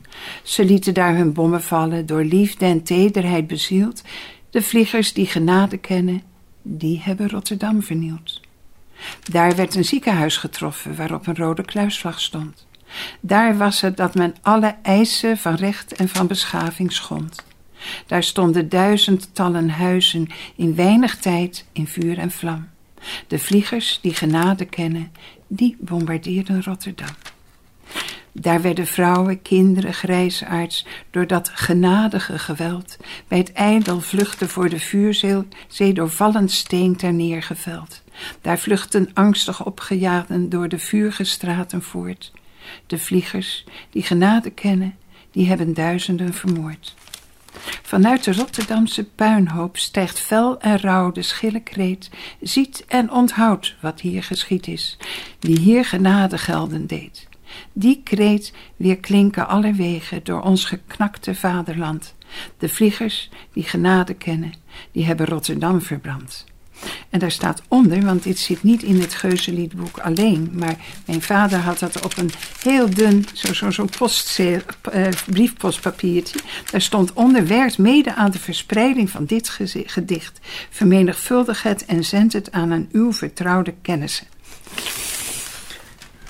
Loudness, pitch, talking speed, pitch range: -19 LUFS, 185 Hz, 130 wpm, 175-205 Hz